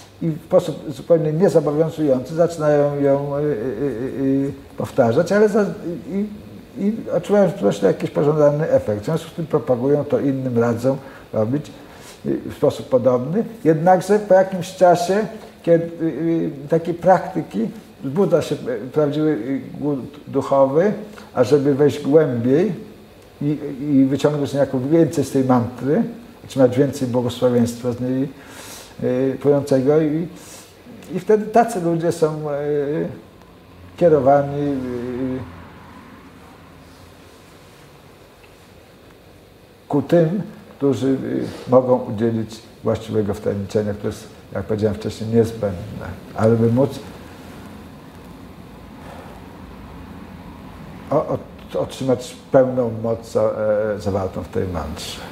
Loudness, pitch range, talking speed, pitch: -19 LUFS, 115-165 Hz, 105 wpm, 140 Hz